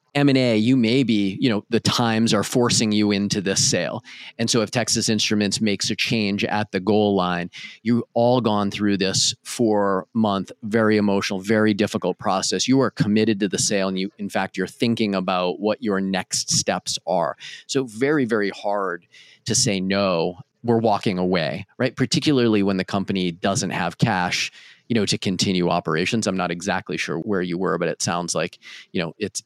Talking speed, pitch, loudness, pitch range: 190 wpm, 105 Hz, -21 LUFS, 100-115 Hz